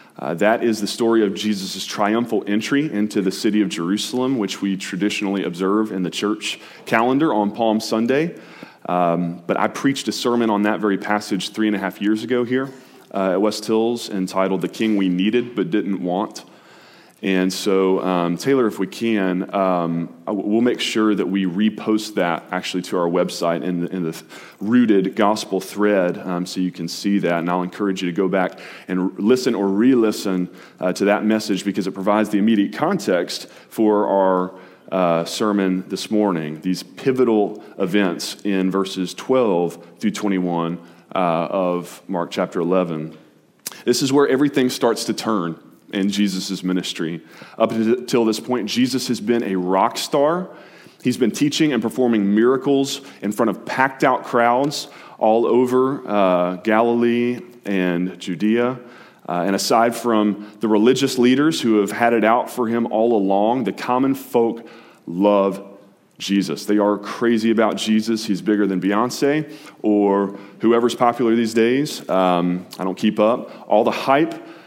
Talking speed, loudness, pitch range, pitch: 165 wpm, -20 LUFS, 95-115 Hz, 105 Hz